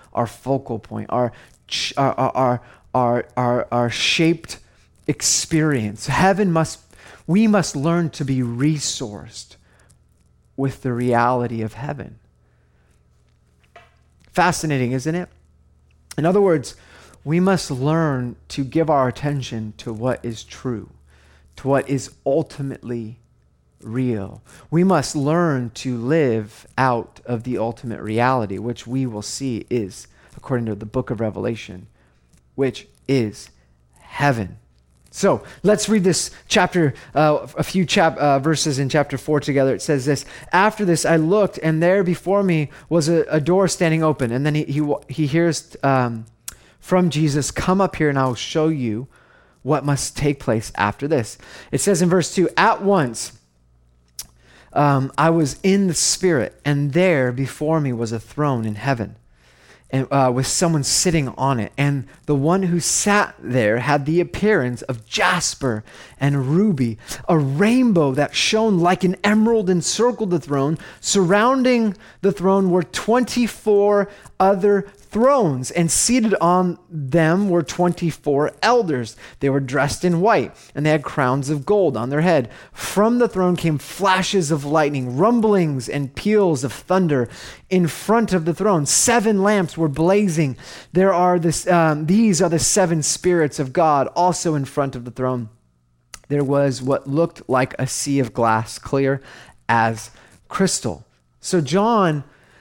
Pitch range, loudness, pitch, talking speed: 120-175 Hz, -19 LUFS, 145 Hz, 150 wpm